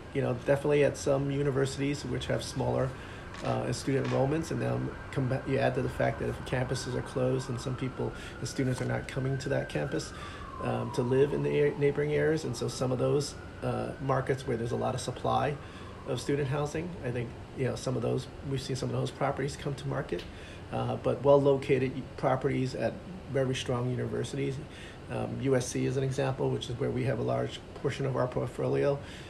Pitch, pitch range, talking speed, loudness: 130 Hz, 120-140 Hz, 205 wpm, -31 LUFS